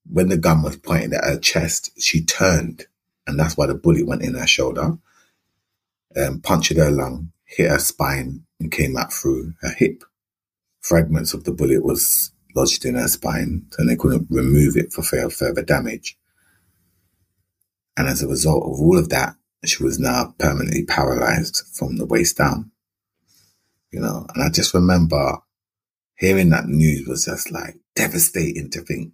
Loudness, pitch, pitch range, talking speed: -19 LUFS, 80 Hz, 70-90 Hz, 170 wpm